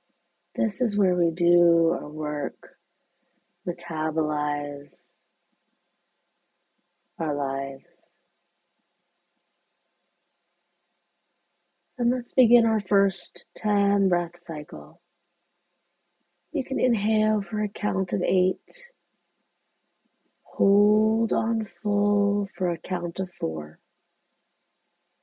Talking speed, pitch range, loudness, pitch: 80 wpm, 175-200 Hz, -25 LUFS, 175 Hz